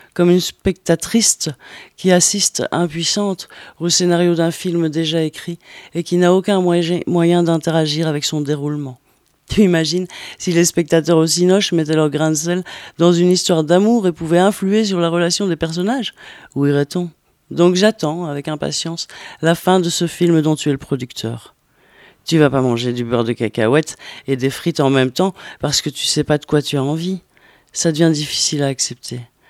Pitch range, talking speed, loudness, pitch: 150-175 Hz, 185 wpm, -16 LUFS, 165 Hz